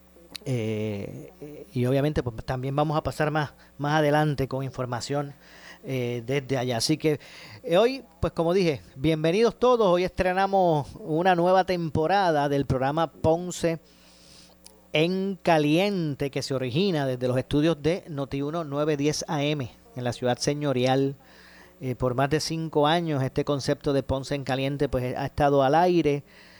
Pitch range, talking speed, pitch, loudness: 130-160 Hz, 145 wpm, 145 Hz, -25 LUFS